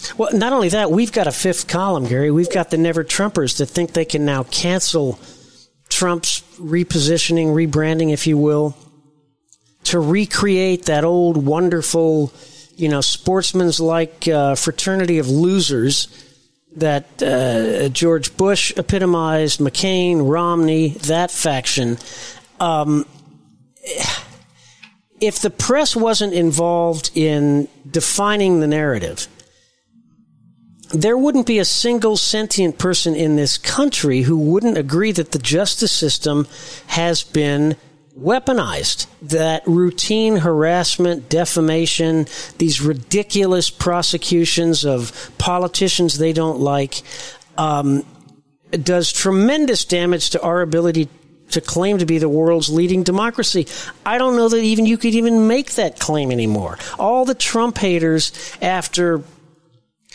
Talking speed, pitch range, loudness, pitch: 120 wpm, 155-185 Hz, -17 LUFS, 165 Hz